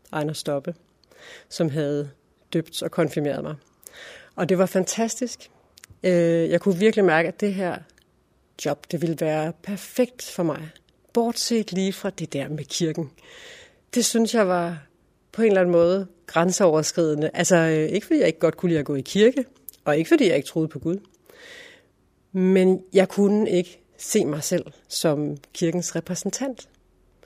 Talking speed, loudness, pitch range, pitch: 160 wpm, -23 LUFS, 160-205 Hz, 180 Hz